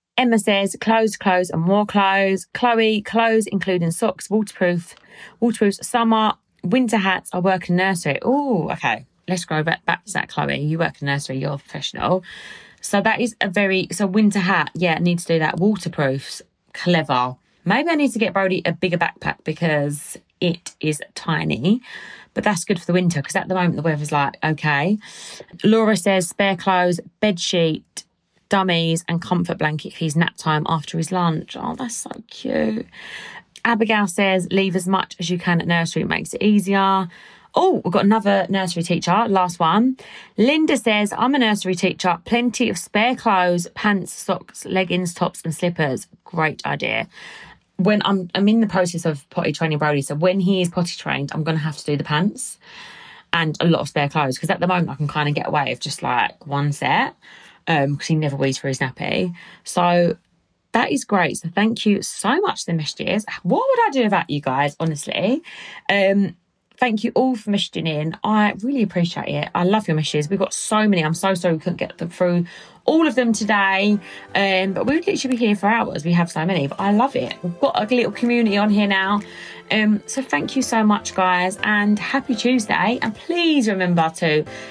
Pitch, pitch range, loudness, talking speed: 190 Hz, 165-215 Hz, -20 LUFS, 195 wpm